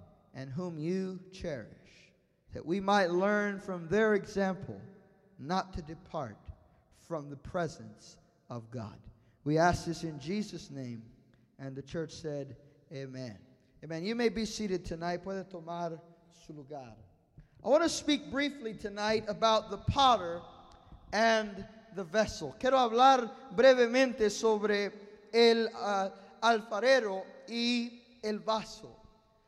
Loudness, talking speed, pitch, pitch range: -31 LUFS, 125 wpm, 190 Hz, 150-220 Hz